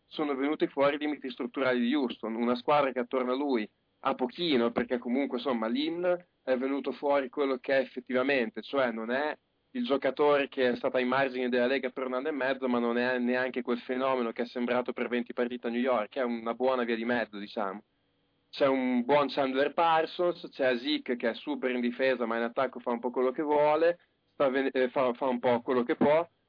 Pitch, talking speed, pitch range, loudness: 130 Hz, 220 wpm, 120-140 Hz, -30 LUFS